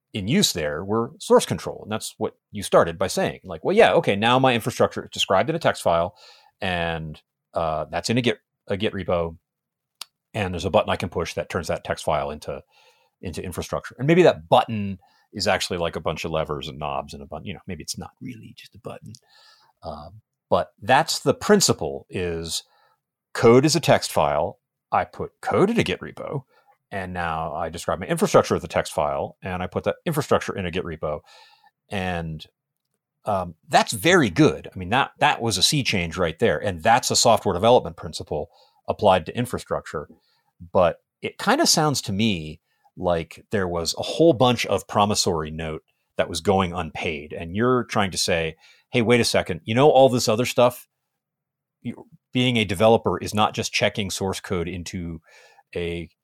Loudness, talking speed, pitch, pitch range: -22 LUFS, 195 wpm, 105 Hz, 85-125 Hz